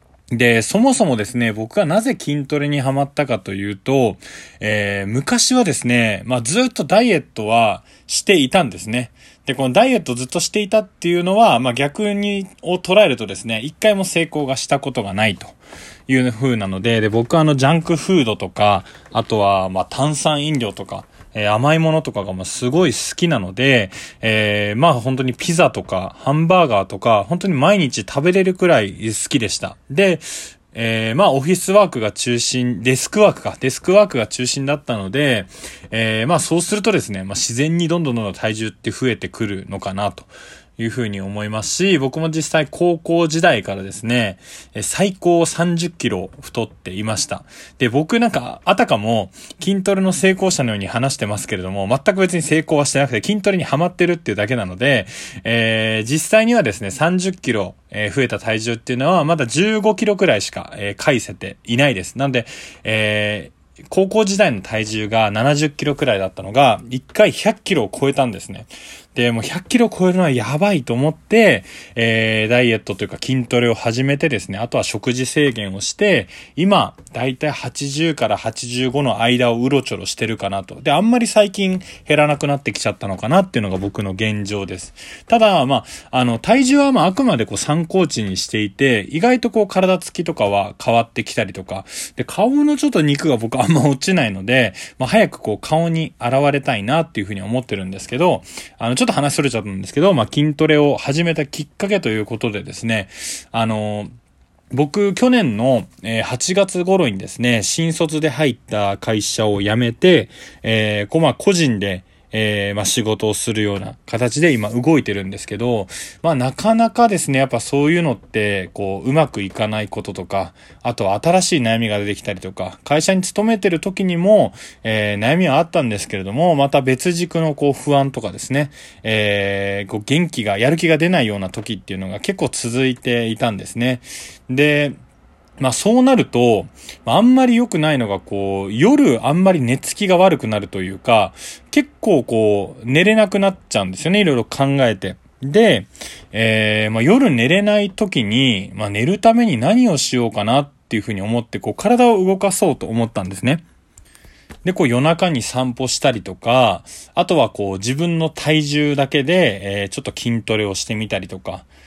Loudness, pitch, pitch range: -17 LUFS, 130 Hz, 110-170 Hz